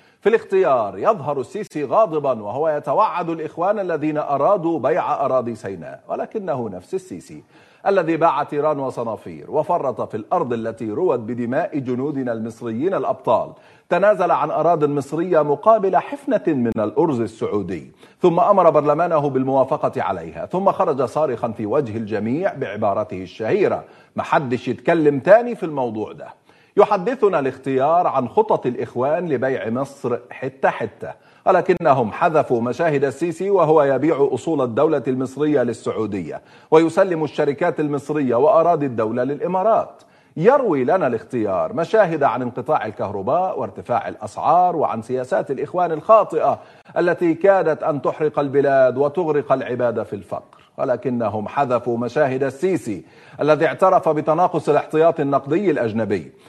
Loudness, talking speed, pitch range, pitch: -19 LUFS, 120 wpm, 130-180 Hz, 155 Hz